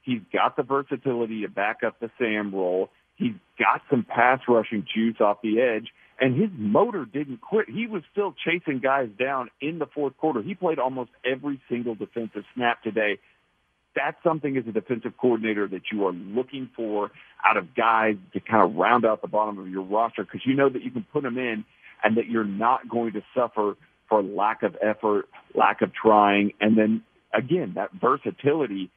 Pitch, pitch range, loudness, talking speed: 120 Hz, 105-135 Hz, -25 LUFS, 195 wpm